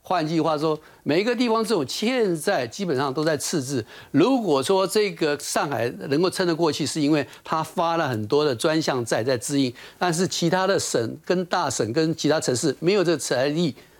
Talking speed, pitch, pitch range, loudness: 290 characters per minute, 160 Hz, 145-185 Hz, -23 LUFS